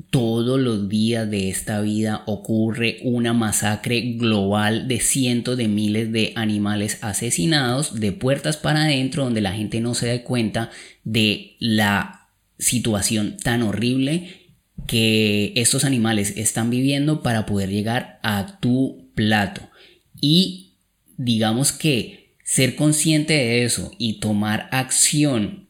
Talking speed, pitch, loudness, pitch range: 125 wpm, 115 Hz, -20 LUFS, 105-130 Hz